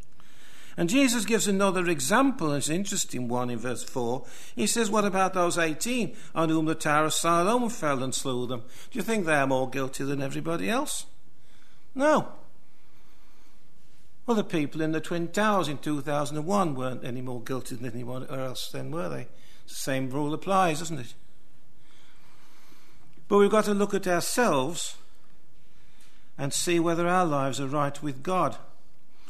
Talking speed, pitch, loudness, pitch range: 170 wpm, 160 Hz, -27 LUFS, 135-195 Hz